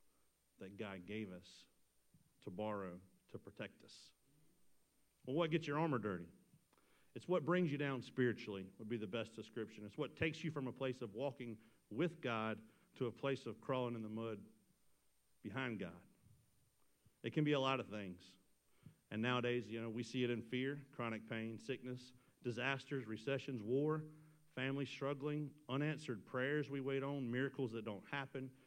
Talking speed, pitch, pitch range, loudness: 165 wpm, 125 Hz, 110-140 Hz, -43 LUFS